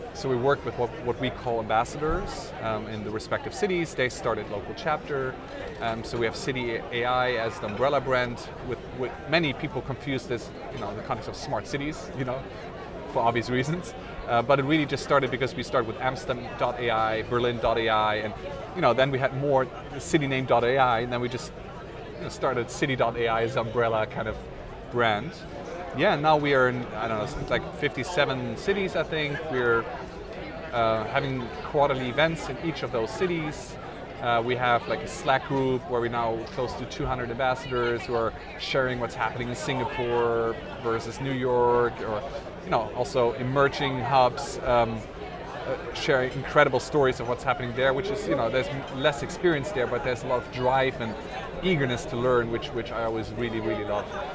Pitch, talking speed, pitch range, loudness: 125 Hz, 185 wpm, 115-140 Hz, -27 LUFS